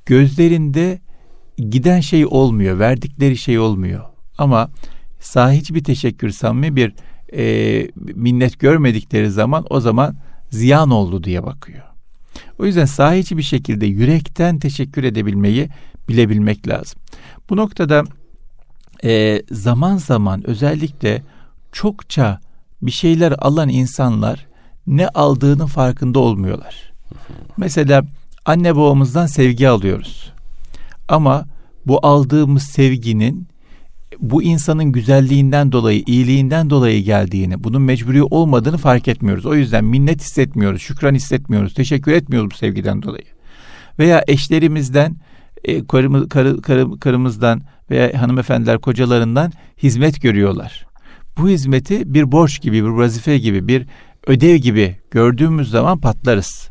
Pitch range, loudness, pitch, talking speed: 115-150 Hz, -15 LUFS, 135 Hz, 110 wpm